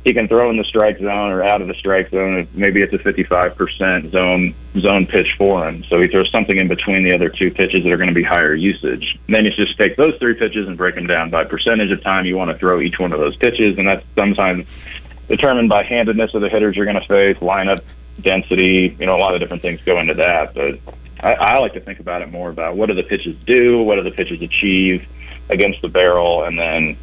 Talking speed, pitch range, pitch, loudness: 255 wpm, 85-105 Hz, 95 Hz, -15 LUFS